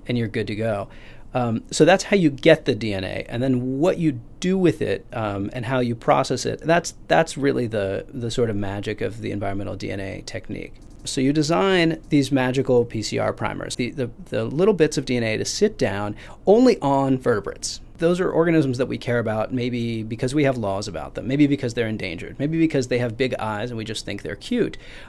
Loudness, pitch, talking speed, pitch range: -22 LUFS, 125 Hz, 215 wpm, 110-145 Hz